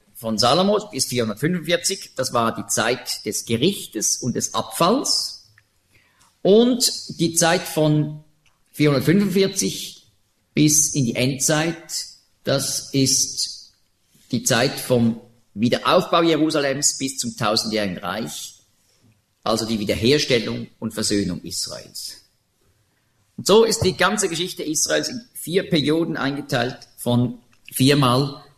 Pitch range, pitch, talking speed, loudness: 115-165 Hz, 135 Hz, 110 wpm, -20 LUFS